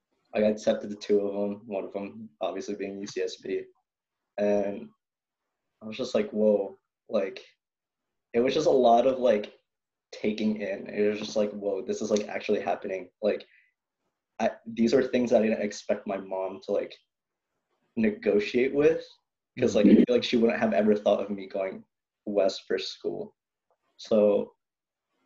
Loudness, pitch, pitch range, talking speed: -27 LUFS, 105 Hz, 100-115 Hz, 160 wpm